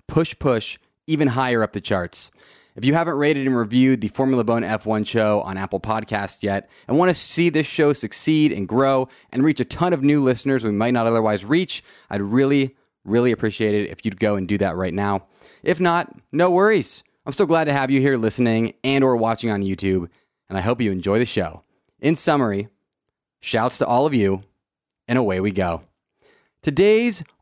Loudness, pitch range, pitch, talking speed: -20 LUFS, 100-140 Hz, 115 Hz, 200 wpm